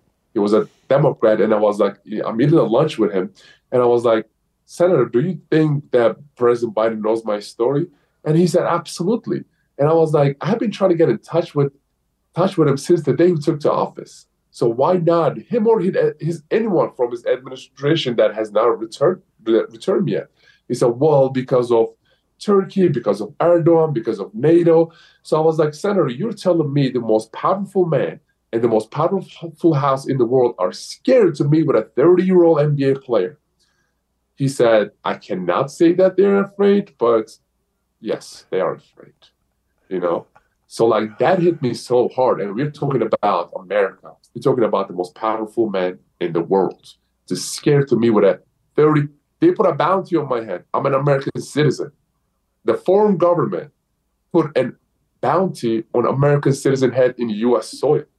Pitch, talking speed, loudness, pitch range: 155 Hz, 185 wpm, -18 LUFS, 125-175 Hz